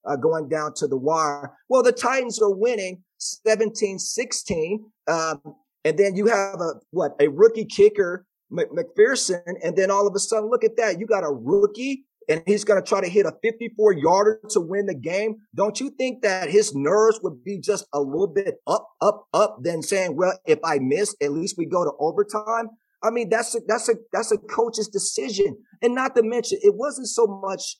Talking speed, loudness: 205 wpm, -22 LUFS